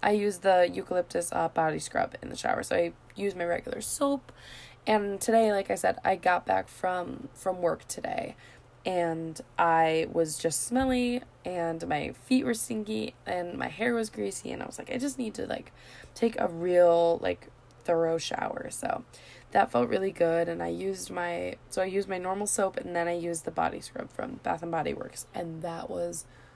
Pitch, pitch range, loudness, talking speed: 180 Hz, 165-210 Hz, -29 LUFS, 200 wpm